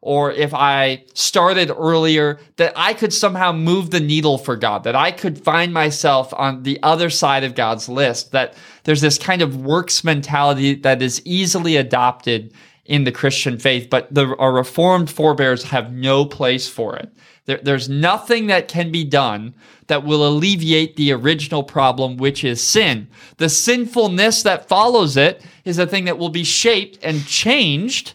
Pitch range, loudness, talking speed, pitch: 135-175 Hz, -16 LUFS, 175 wpm, 150 Hz